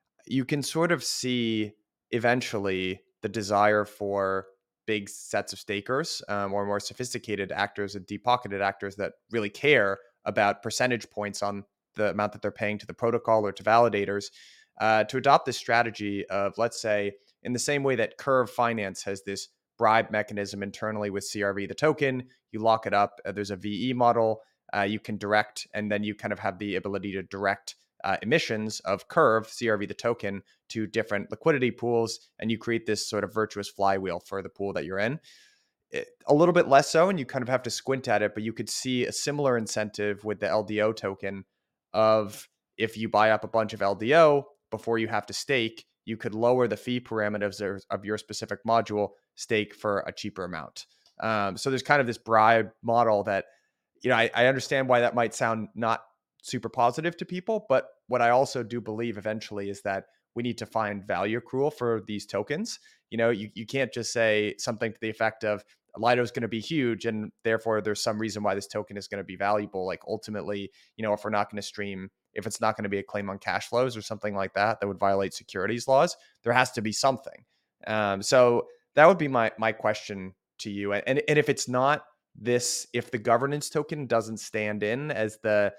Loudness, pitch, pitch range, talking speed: -27 LUFS, 110 Hz, 100-120 Hz, 210 wpm